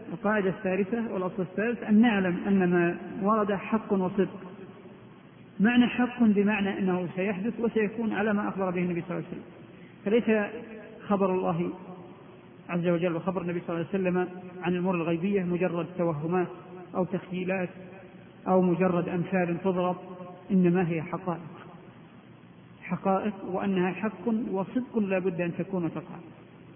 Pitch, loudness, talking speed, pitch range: 185 Hz, -28 LUFS, 135 wpm, 180-200 Hz